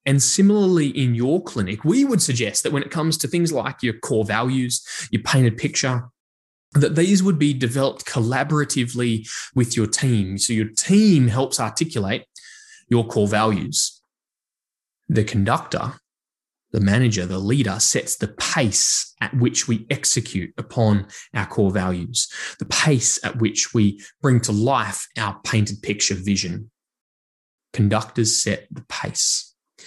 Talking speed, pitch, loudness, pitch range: 145 wpm, 120 Hz, -20 LUFS, 105-140 Hz